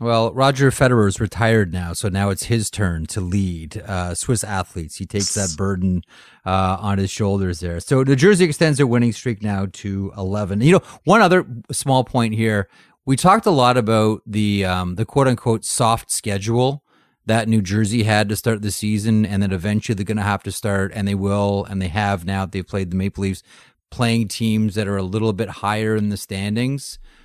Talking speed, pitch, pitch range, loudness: 210 wpm, 105 Hz, 100-115 Hz, -19 LUFS